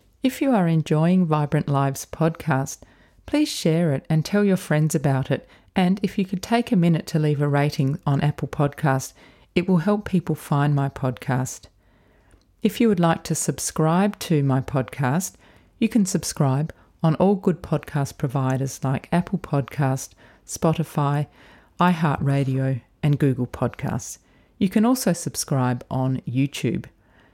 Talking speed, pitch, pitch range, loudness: 150 wpm, 150 Hz, 135-180 Hz, -23 LUFS